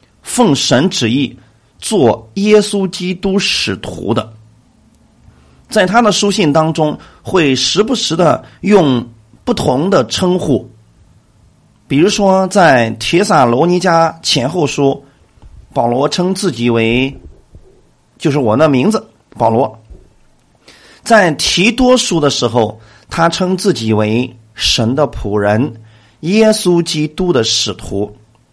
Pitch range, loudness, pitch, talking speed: 115-185 Hz, -12 LUFS, 140 Hz, 165 characters per minute